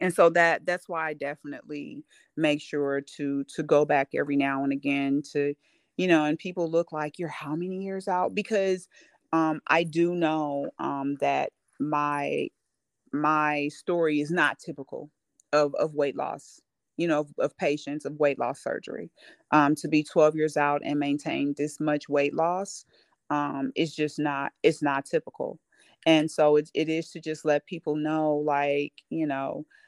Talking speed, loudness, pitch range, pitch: 175 wpm, -27 LUFS, 145-165 Hz, 150 Hz